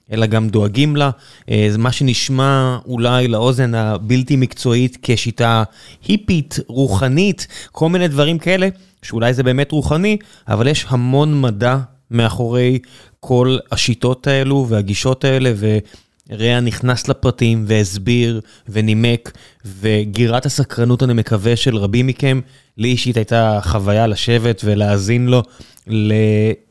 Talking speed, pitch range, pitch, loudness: 115 wpm, 110-135 Hz, 120 Hz, -16 LUFS